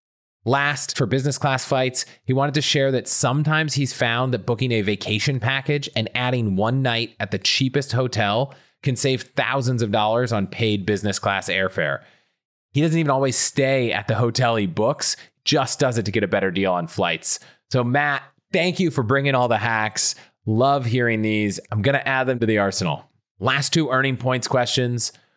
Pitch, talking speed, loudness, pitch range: 125 Hz, 190 wpm, -21 LUFS, 110-135 Hz